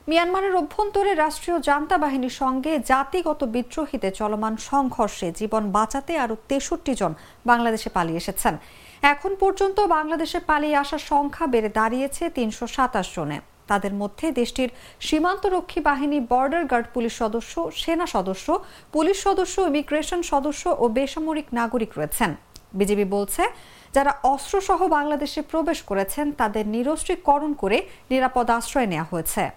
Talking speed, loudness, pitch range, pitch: 120 wpm, -23 LUFS, 225-325 Hz, 280 Hz